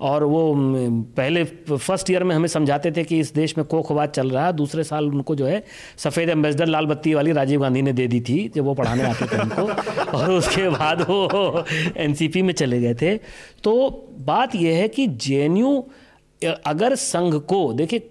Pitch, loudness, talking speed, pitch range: 160 Hz, -21 LUFS, 190 wpm, 145-180 Hz